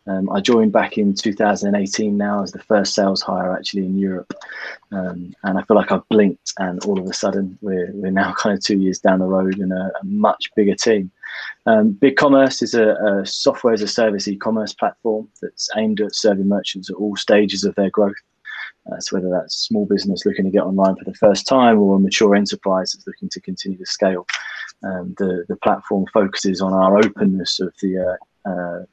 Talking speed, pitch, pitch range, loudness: 215 wpm, 100 Hz, 95-110 Hz, -18 LUFS